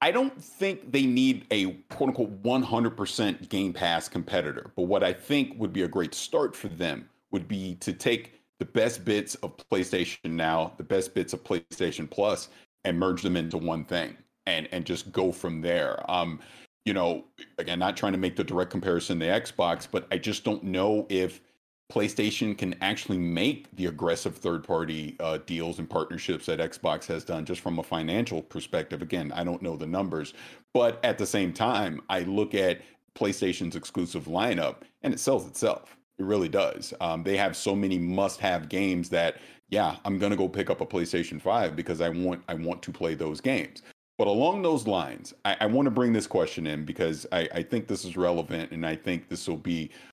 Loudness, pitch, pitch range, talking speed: -29 LUFS, 90 Hz, 85-105 Hz, 200 wpm